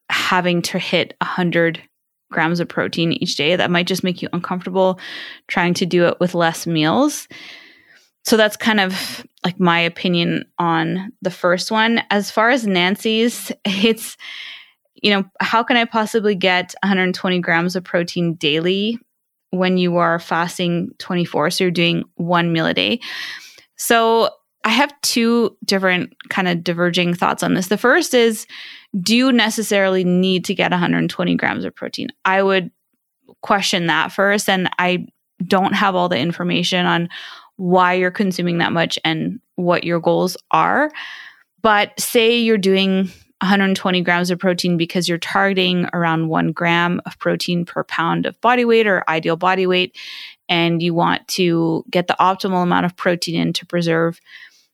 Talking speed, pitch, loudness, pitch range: 160 wpm, 185 Hz, -17 LUFS, 175-210 Hz